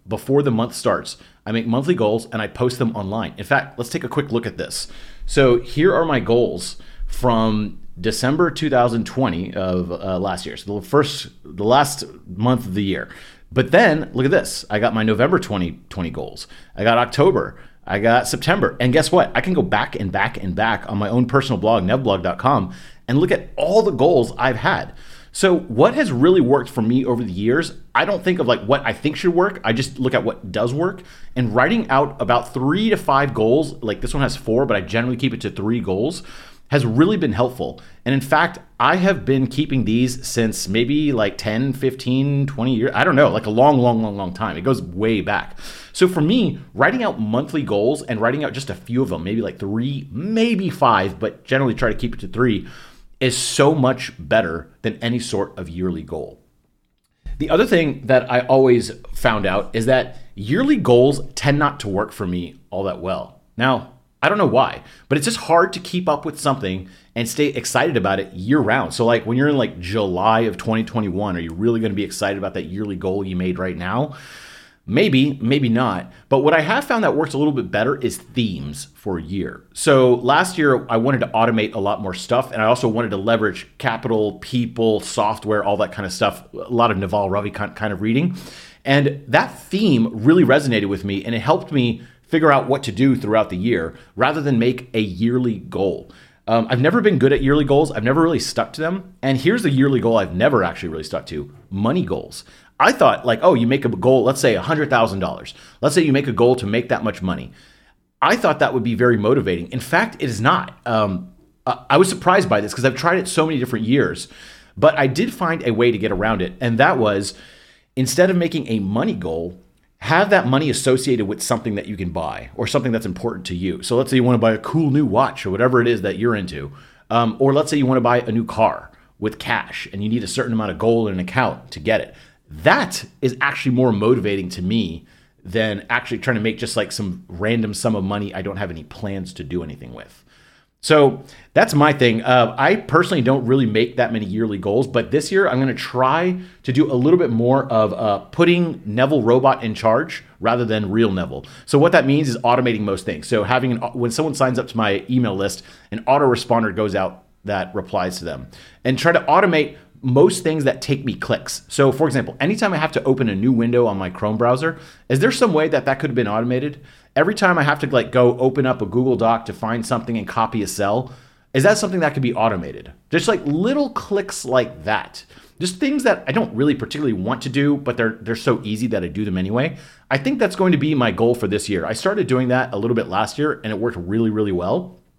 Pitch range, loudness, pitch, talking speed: 110-140 Hz, -19 LUFS, 120 Hz, 230 wpm